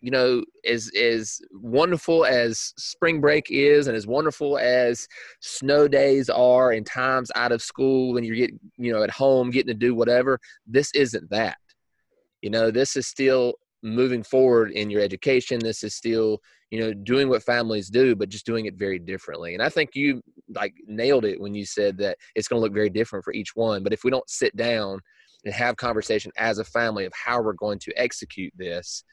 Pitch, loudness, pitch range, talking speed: 120 Hz, -23 LUFS, 110-130 Hz, 205 wpm